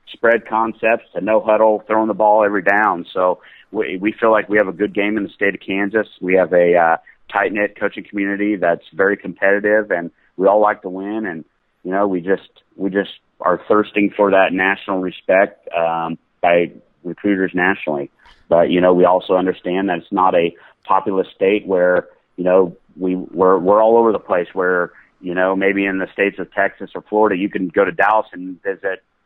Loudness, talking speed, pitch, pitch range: -17 LUFS, 205 wpm, 100 Hz, 90-105 Hz